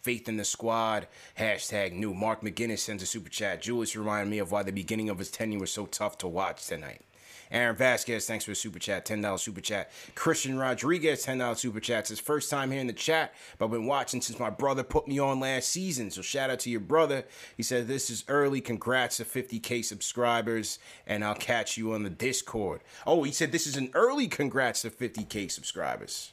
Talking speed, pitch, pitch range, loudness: 220 wpm, 115 Hz, 105-135 Hz, -30 LUFS